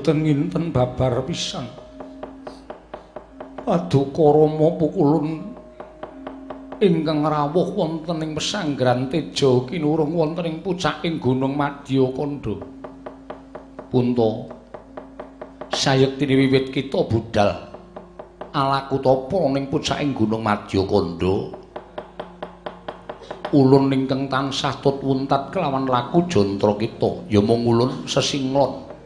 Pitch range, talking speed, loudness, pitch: 130-160 Hz, 90 wpm, -21 LUFS, 140 Hz